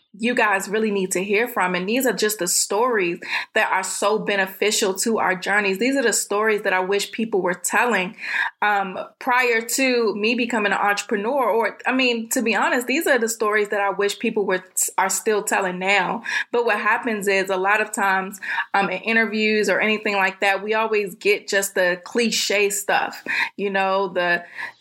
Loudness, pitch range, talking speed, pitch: -20 LUFS, 195-230 Hz, 200 wpm, 210 Hz